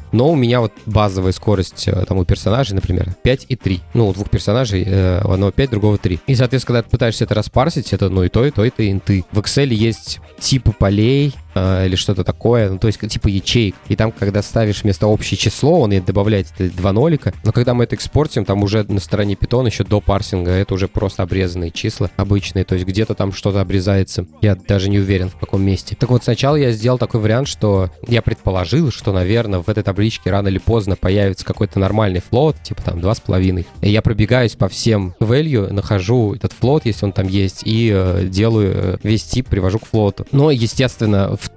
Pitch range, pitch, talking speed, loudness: 95-115 Hz, 105 Hz, 215 wpm, -16 LUFS